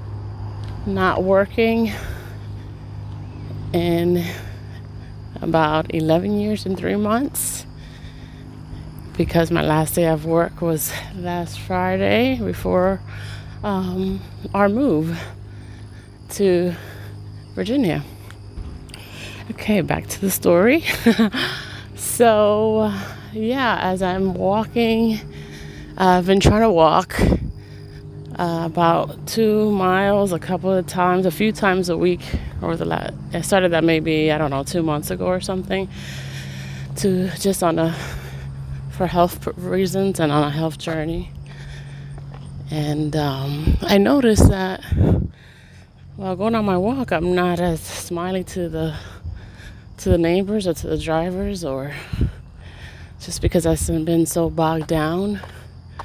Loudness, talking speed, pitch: -20 LUFS, 120 wpm, 165 Hz